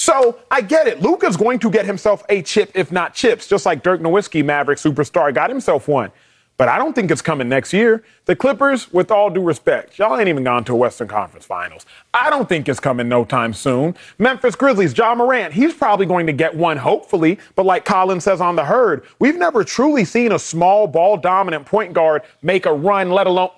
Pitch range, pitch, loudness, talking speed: 160-225 Hz, 190 Hz, -16 LUFS, 220 wpm